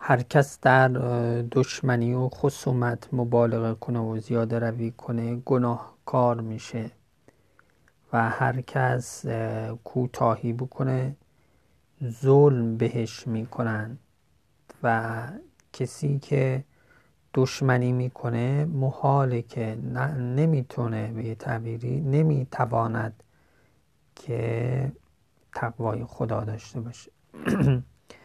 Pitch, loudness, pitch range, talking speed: 120 Hz, -26 LUFS, 115-130 Hz, 85 wpm